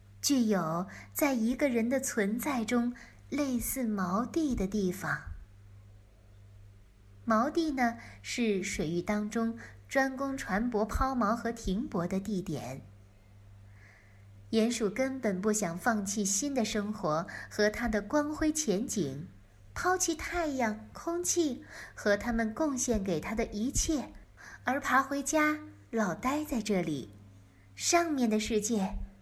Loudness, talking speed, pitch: -31 LUFS, 175 characters per minute, 215 Hz